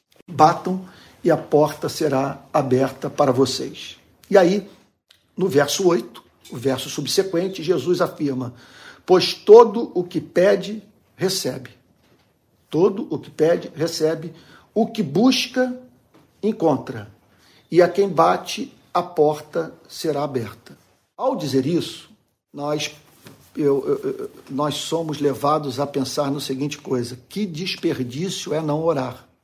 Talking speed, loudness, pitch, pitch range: 120 wpm, -21 LUFS, 155 Hz, 135-185 Hz